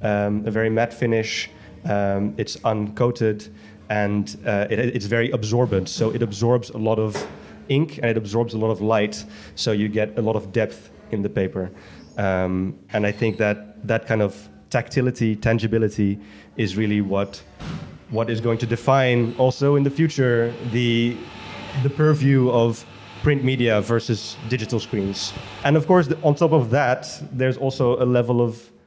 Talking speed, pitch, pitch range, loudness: 170 wpm, 115 Hz, 105-125 Hz, -22 LUFS